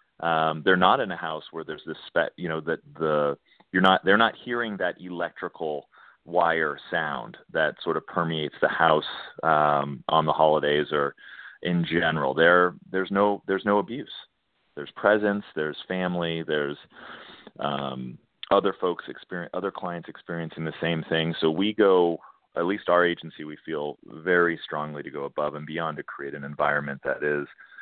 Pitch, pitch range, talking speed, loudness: 80 Hz, 75-90 Hz, 170 wpm, -25 LUFS